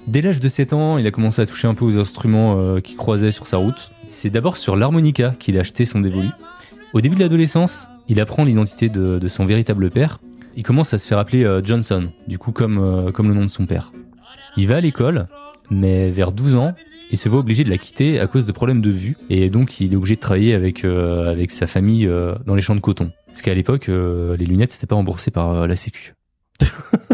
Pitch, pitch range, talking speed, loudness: 110 Hz, 95-125 Hz, 245 wpm, -18 LUFS